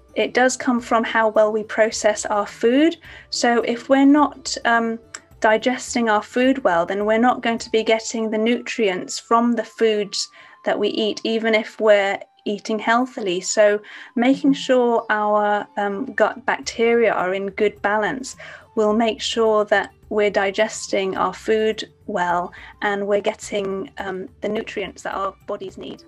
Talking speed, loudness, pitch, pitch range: 160 wpm, -20 LUFS, 220 Hz, 205-235 Hz